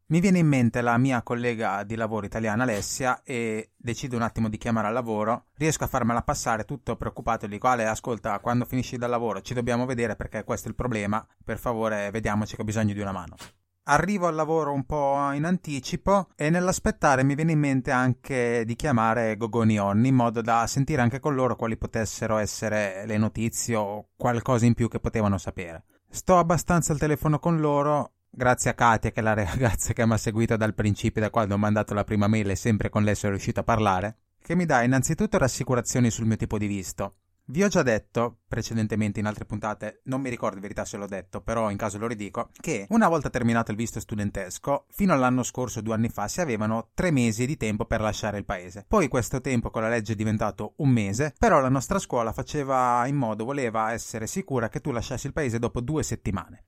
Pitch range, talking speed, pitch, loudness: 110-130 Hz, 215 wpm, 115 Hz, -26 LUFS